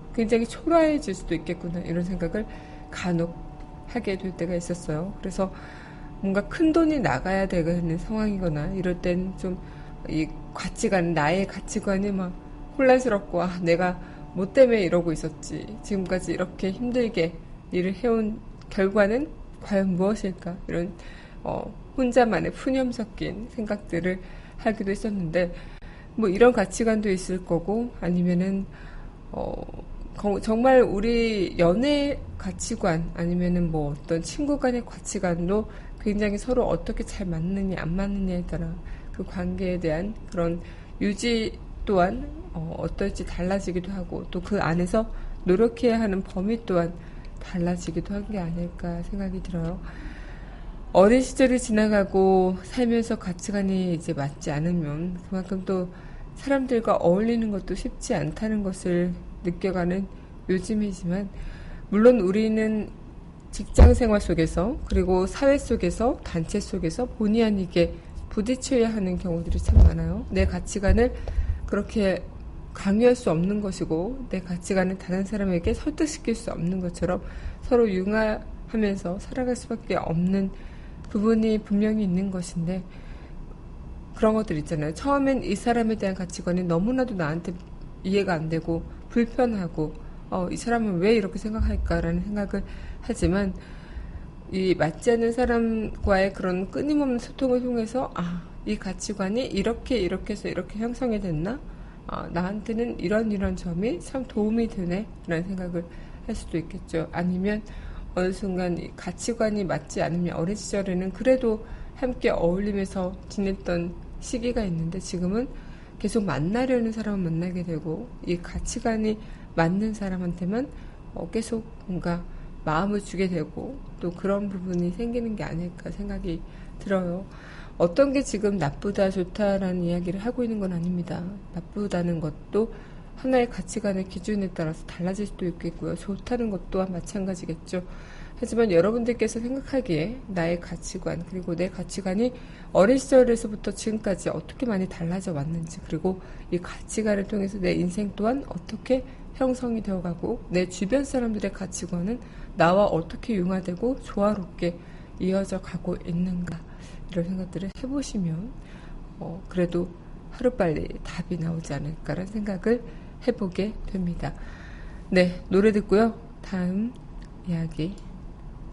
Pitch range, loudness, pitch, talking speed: 175-220 Hz, -26 LUFS, 190 Hz, 300 characters per minute